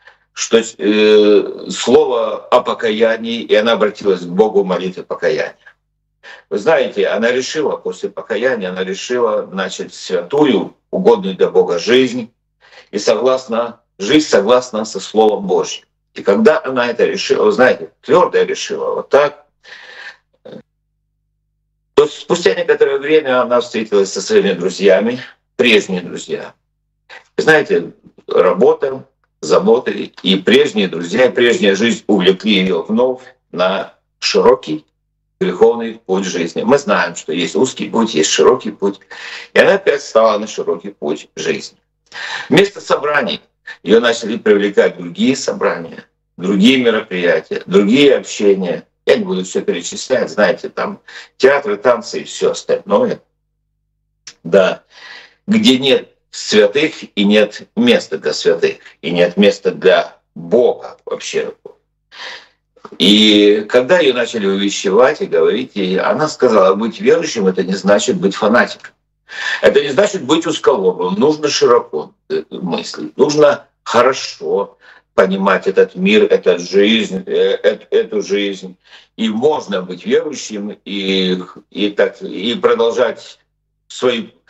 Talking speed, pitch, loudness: 120 wpm, 225 Hz, -14 LUFS